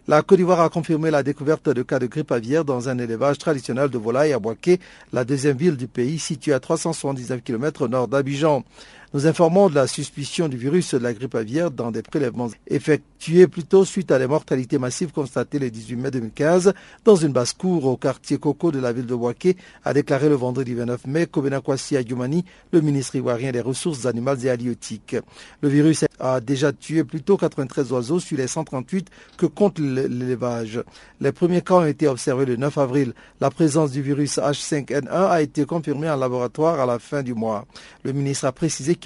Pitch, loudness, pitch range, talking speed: 145 Hz, -21 LUFS, 130-160 Hz, 195 wpm